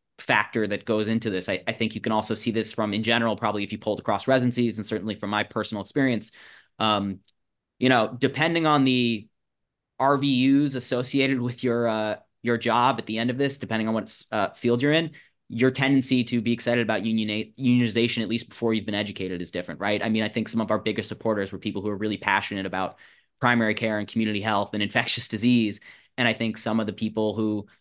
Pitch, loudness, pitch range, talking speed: 110 Hz, -25 LUFS, 105-120 Hz, 220 wpm